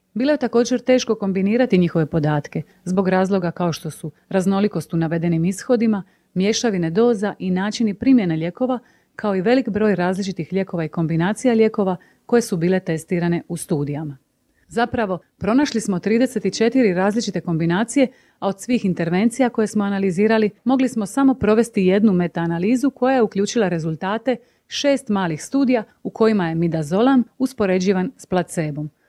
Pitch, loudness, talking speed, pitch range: 200 Hz, -20 LUFS, 145 wpm, 175-235 Hz